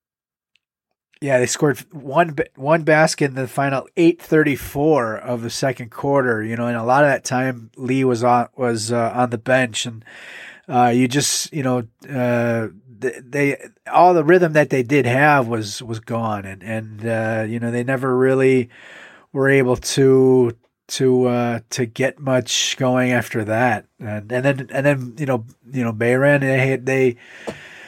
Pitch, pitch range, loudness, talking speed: 125 Hz, 120-135 Hz, -18 LUFS, 170 wpm